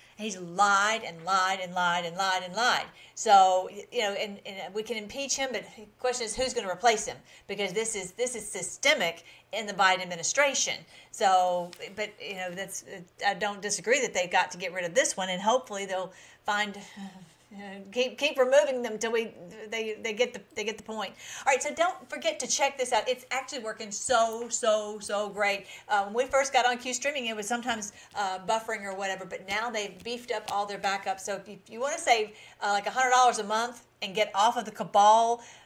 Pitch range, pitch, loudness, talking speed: 195-240 Hz, 215 Hz, -28 LUFS, 220 wpm